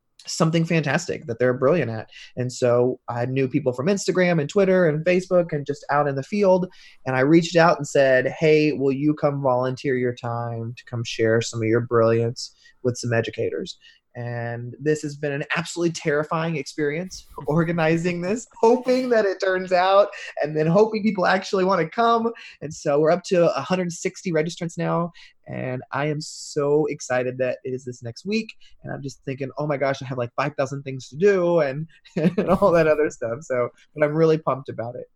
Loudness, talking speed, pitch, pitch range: -22 LUFS, 195 wpm, 150 Hz, 130-180 Hz